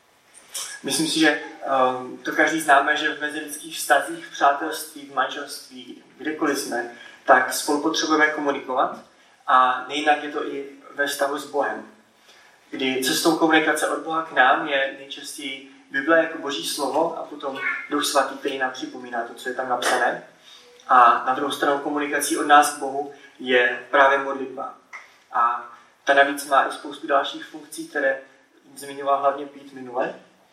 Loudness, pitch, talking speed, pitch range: -22 LUFS, 140 Hz, 155 wpm, 135-150 Hz